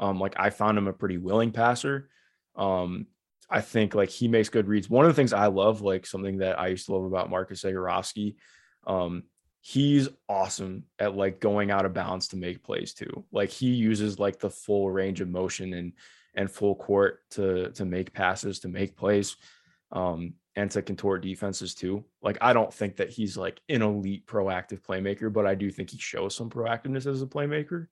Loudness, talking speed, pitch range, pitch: -28 LUFS, 200 wpm, 95-110 Hz, 100 Hz